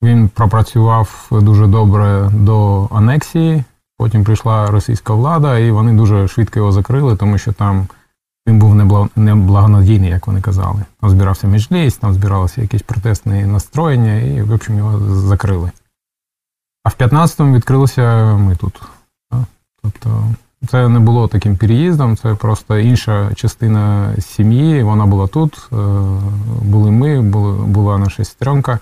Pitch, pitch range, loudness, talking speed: 105 Hz, 100-115 Hz, -13 LUFS, 130 wpm